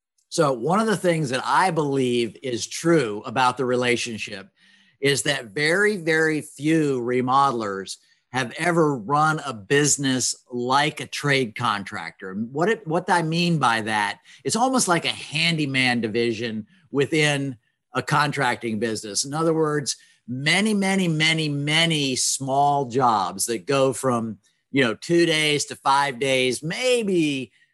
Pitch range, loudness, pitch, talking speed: 125-160 Hz, -22 LUFS, 140 Hz, 140 wpm